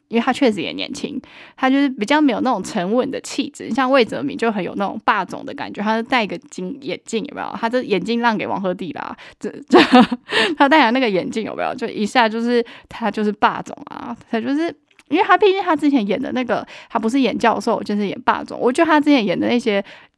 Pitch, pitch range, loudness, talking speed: 250 Hz, 225-285 Hz, -18 LUFS, 340 characters per minute